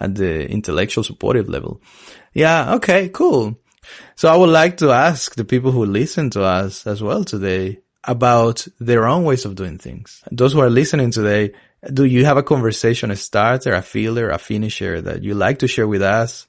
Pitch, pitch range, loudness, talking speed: 115 Hz, 100-135 Hz, -16 LUFS, 195 wpm